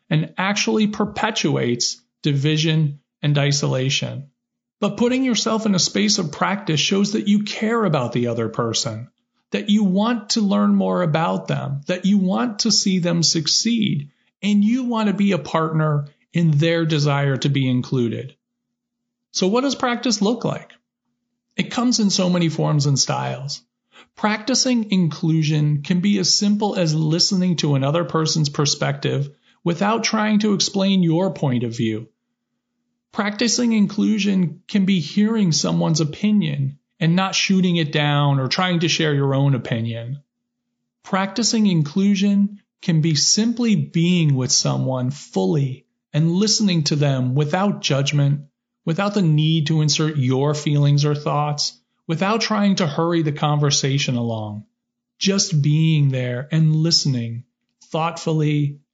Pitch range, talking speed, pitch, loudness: 145-210 Hz, 145 wpm, 170 Hz, -19 LUFS